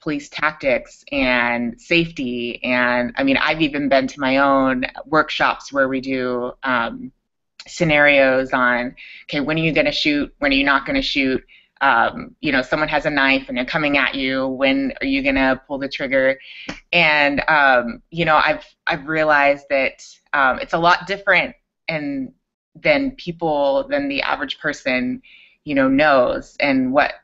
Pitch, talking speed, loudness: 150 Hz, 165 wpm, -18 LUFS